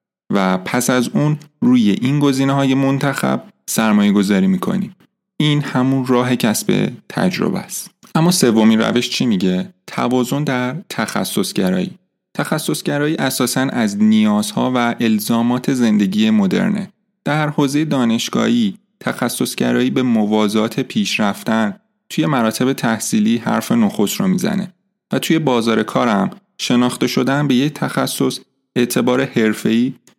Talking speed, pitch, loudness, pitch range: 120 wpm, 150 Hz, -17 LUFS, 125-200 Hz